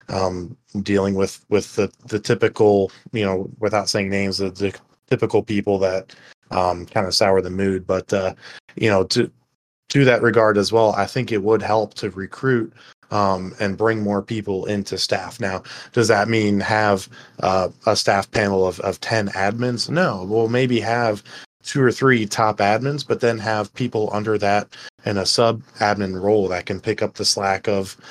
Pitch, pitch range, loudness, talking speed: 105 Hz, 95-115 Hz, -20 LUFS, 185 wpm